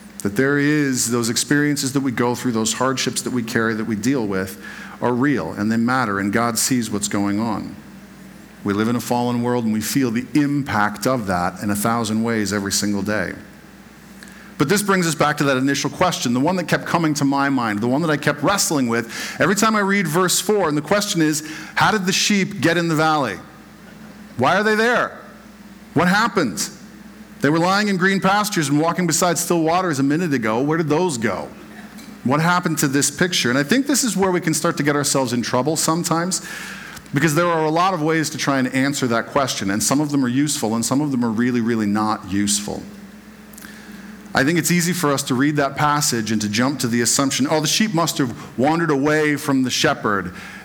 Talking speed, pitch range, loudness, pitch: 225 wpm, 120-175 Hz, -19 LUFS, 145 Hz